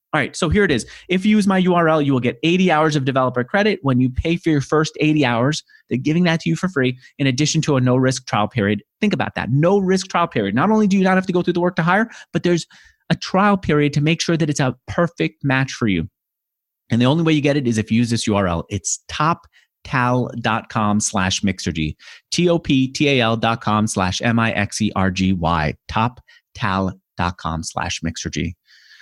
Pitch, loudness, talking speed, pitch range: 130 Hz, -19 LUFS, 235 wpm, 105-165 Hz